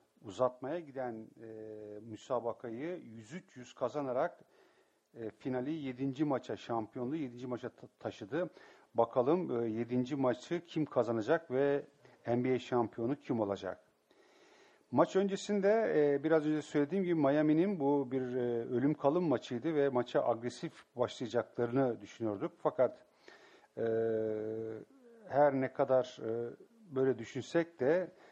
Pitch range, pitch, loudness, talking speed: 120-155 Hz, 130 Hz, -35 LUFS, 115 wpm